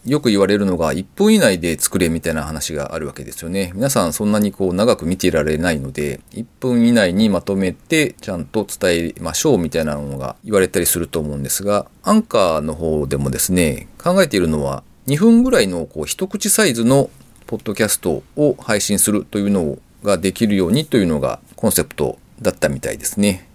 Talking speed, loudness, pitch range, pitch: 420 characters per minute, -17 LUFS, 80-115 Hz, 95 Hz